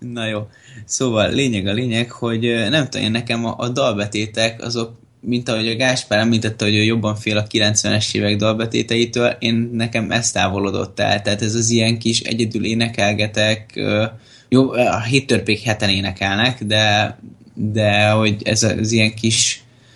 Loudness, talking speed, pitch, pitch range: -18 LUFS, 155 wpm, 115 Hz, 105-120 Hz